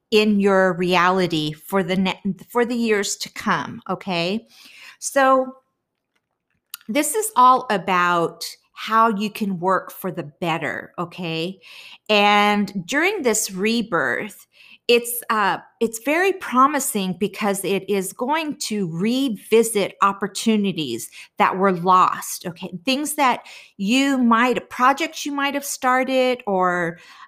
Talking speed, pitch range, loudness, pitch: 120 wpm, 185-260 Hz, -20 LUFS, 215 Hz